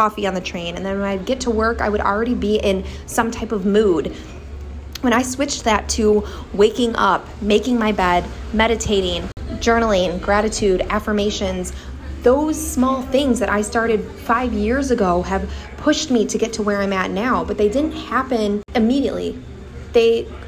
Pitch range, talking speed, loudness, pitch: 200-240 Hz, 175 wpm, -19 LUFS, 215 Hz